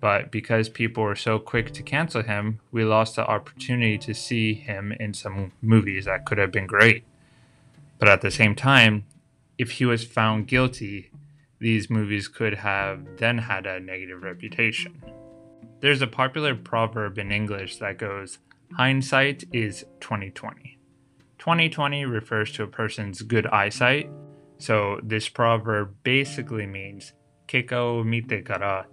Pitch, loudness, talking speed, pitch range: 110 Hz, -23 LUFS, 145 wpm, 105-130 Hz